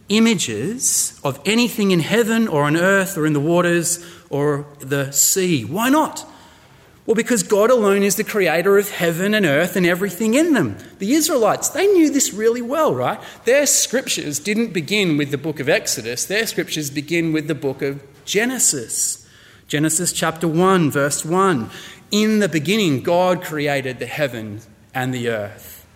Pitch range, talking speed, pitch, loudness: 145-215 Hz, 165 wpm, 180 Hz, -18 LUFS